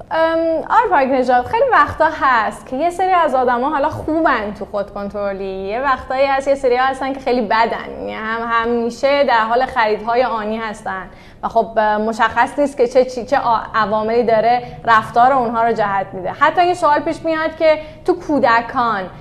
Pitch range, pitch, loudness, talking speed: 220-285 Hz, 245 Hz, -16 LUFS, 170 wpm